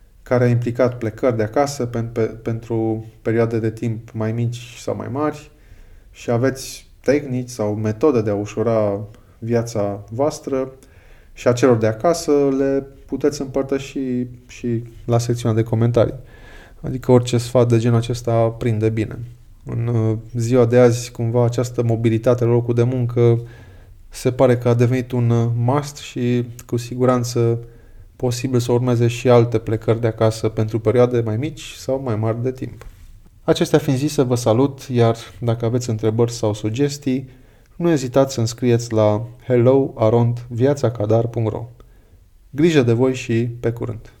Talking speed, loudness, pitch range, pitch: 150 wpm, -19 LUFS, 110-125 Hz, 120 Hz